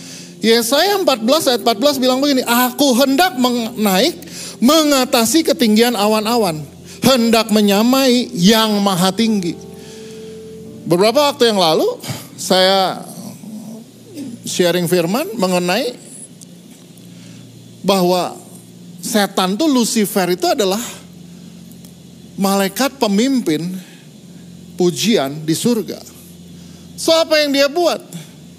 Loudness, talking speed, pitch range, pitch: -15 LUFS, 85 wpm, 185-250 Hz, 215 Hz